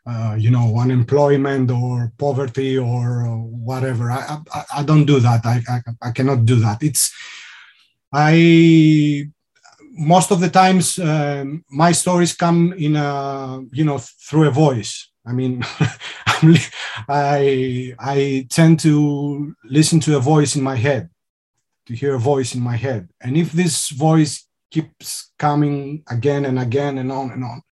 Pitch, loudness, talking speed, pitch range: 140 Hz, -17 LUFS, 150 wpm, 125-150 Hz